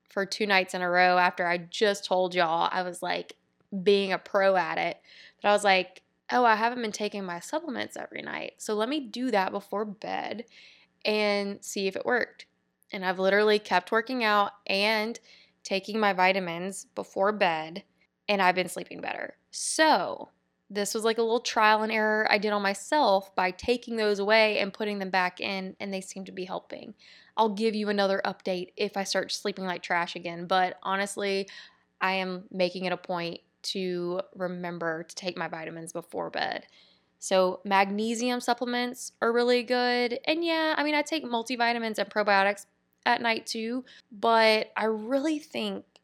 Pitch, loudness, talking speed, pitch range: 200 Hz, -27 LUFS, 180 wpm, 185-225 Hz